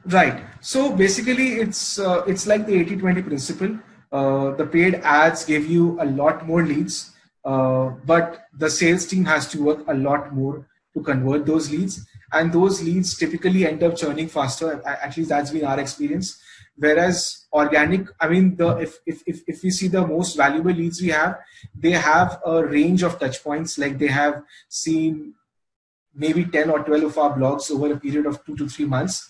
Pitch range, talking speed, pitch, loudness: 145-175 Hz, 190 wpm, 160 Hz, -21 LUFS